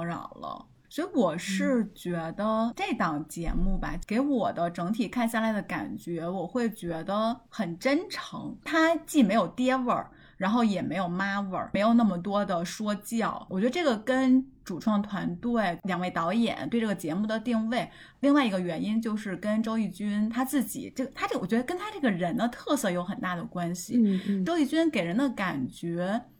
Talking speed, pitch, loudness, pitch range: 280 characters per minute, 220 Hz, -28 LUFS, 185-250 Hz